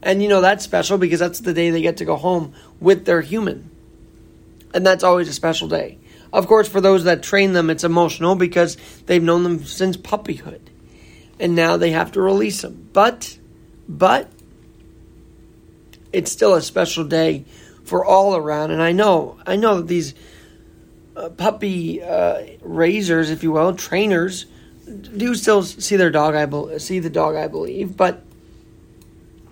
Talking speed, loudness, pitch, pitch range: 170 wpm, -18 LUFS, 175 Hz, 160-190 Hz